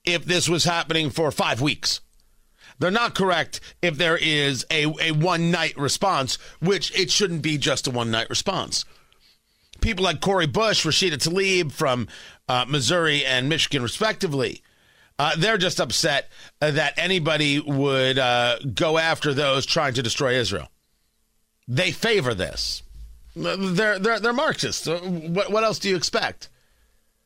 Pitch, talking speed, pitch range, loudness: 160 Hz, 145 wpm, 135-180 Hz, -22 LUFS